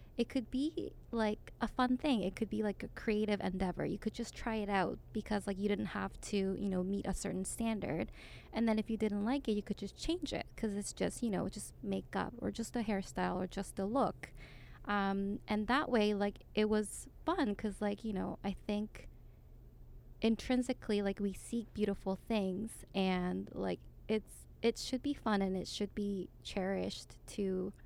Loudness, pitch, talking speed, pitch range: -38 LUFS, 210 Hz, 200 wpm, 195-225 Hz